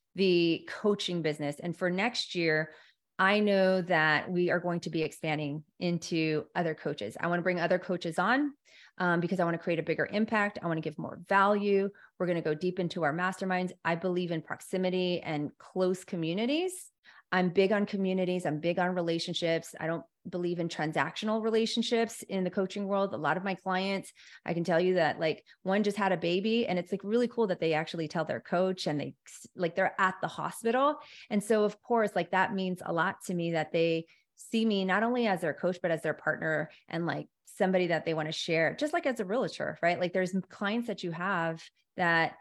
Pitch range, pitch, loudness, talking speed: 165-200 Hz, 180 Hz, -30 LUFS, 215 wpm